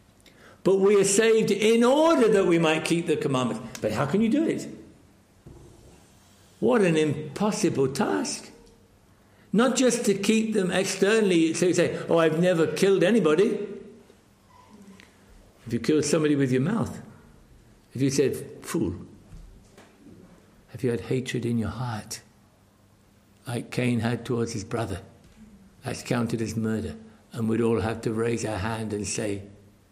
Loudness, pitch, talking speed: -24 LUFS, 130 Hz, 150 wpm